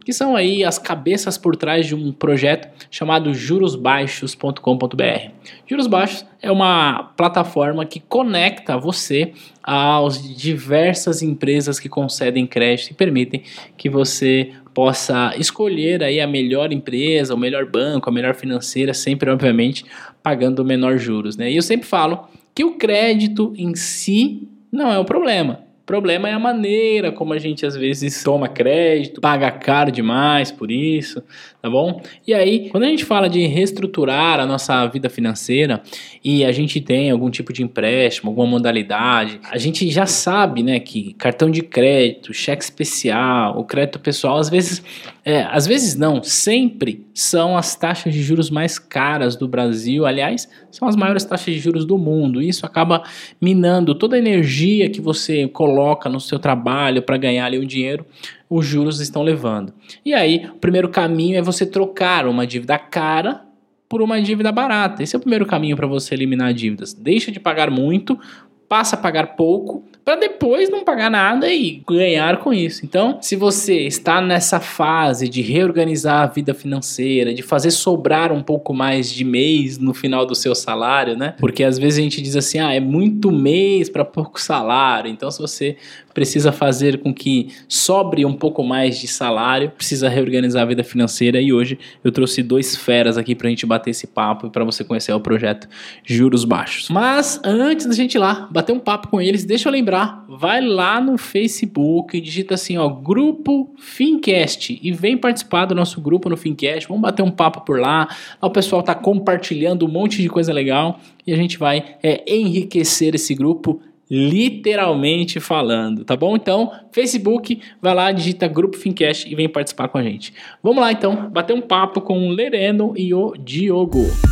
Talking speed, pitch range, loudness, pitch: 175 wpm, 135-190 Hz, -17 LUFS, 155 Hz